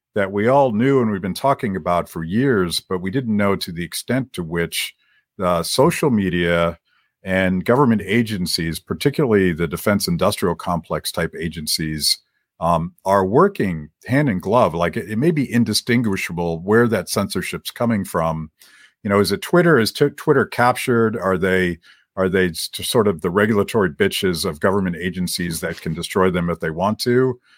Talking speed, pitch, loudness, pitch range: 170 wpm, 95 Hz, -19 LUFS, 85-115 Hz